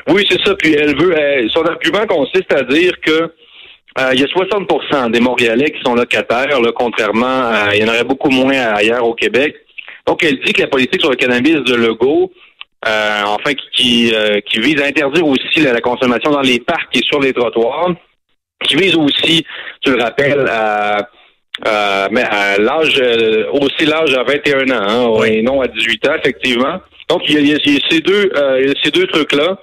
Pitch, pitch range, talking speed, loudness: 135 Hz, 115-160 Hz, 205 wpm, -12 LUFS